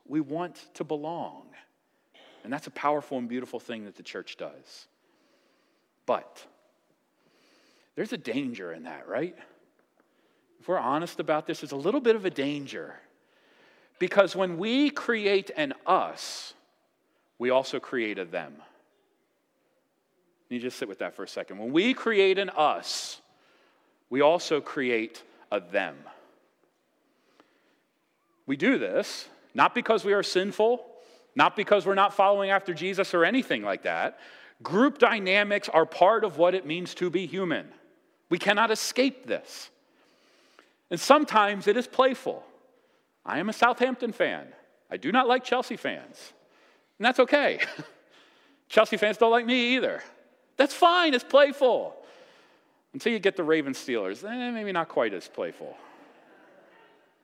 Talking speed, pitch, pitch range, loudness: 145 wpm, 210 Hz, 175-255 Hz, -26 LUFS